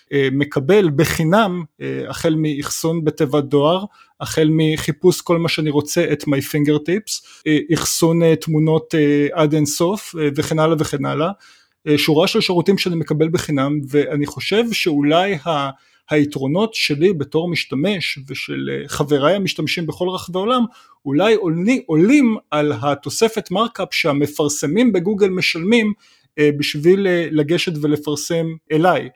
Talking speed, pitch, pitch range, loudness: 115 wpm, 160 Hz, 150-180 Hz, -17 LUFS